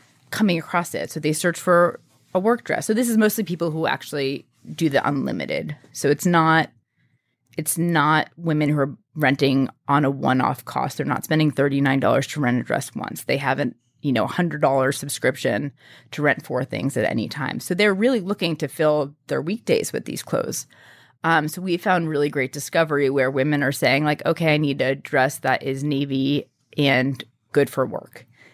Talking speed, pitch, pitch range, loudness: 195 wpm, 150 Hz, 135-170 Hz, -22 LUFS